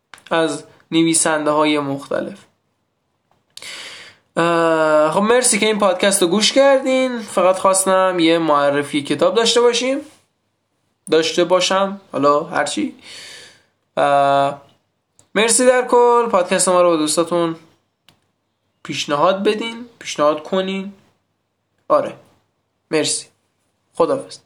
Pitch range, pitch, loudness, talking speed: 155-225 Hz, 180 Hz, -16 LUFS, 95 wpm